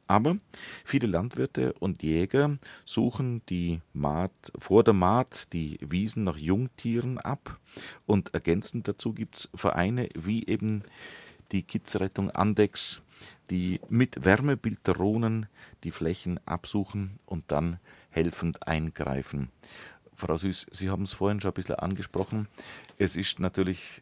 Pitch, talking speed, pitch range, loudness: 95 Hz, 125 wpm, 85-110 Hz, -29 LUFS